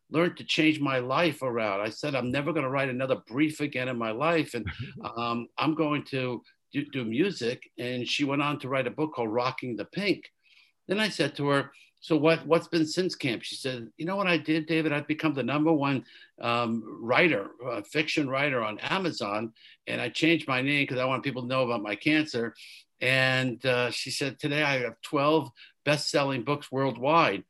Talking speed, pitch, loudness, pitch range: 205 wpm, 140 Hz, -28 LUFS, 125-155 Hz